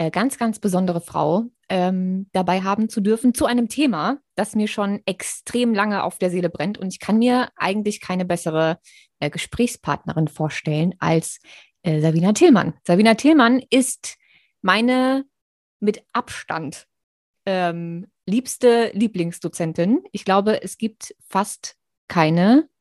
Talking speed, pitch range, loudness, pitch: 130 wpm, 175-235 Hz, -20 LUFS, 195 Hz